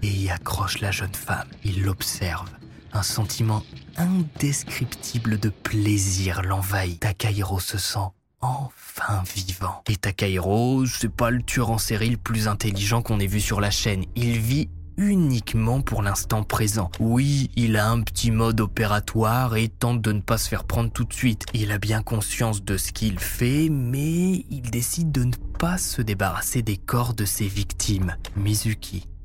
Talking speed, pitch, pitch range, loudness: 170 wpm, 110 Hz, 100-120 Hz, -24 LUFS